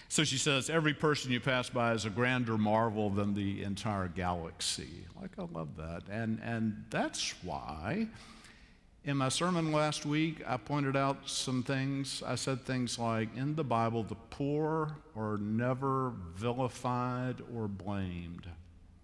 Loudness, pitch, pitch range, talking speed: -34 LUFS, 120 Hz, 100-135 Hz, 150 wpm